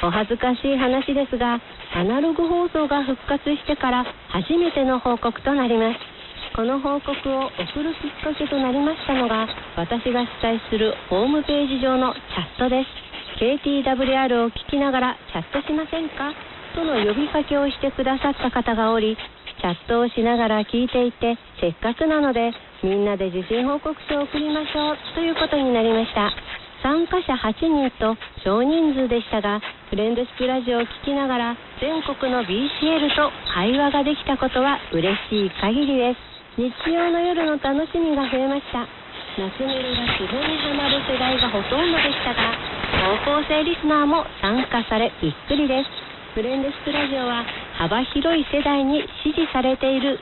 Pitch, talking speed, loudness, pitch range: 265 Hz, 340 characters per minute, -22 LUFS, 235-290 Hz